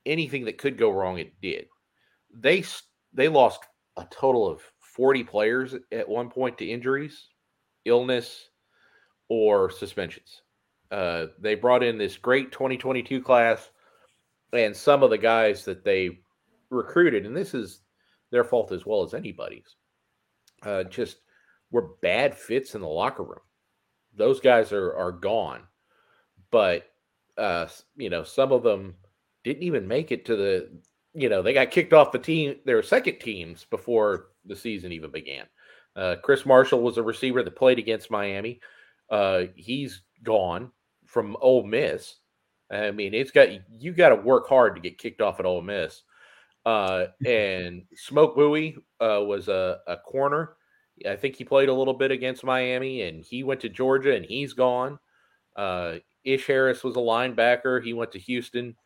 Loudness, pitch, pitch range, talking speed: -24 LUFS, 130 Hz, 115-150 Hz, 165 wpm